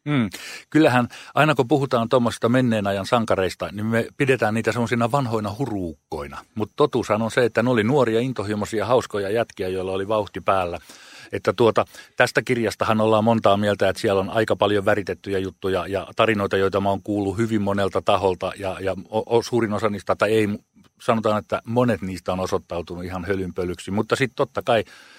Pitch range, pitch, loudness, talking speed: 95-115 Hz, 105 Hz, -22 LUFS, 175 wpm